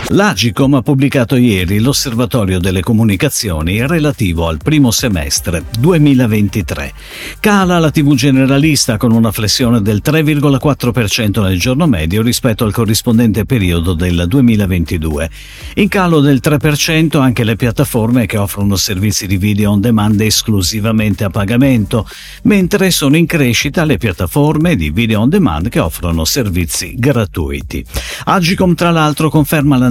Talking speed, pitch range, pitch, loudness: 130 wpm, 100-145 Hz, 115 Hz, -12 LUFS